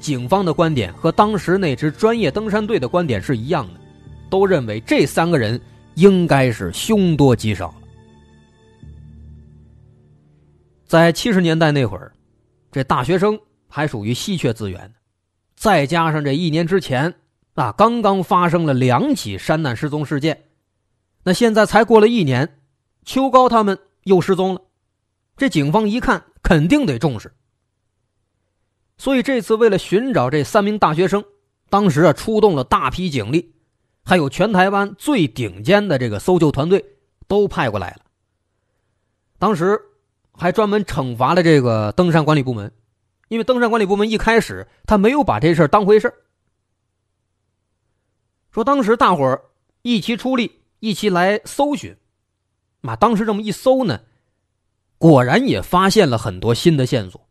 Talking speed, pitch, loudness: 230 characters per minute, 155 Hz, -17 LUFS